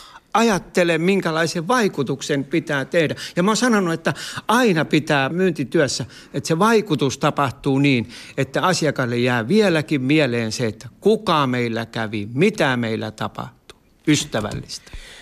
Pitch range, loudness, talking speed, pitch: 135-185 Hz, -20 LUFS, 125 wpm, 150 Hz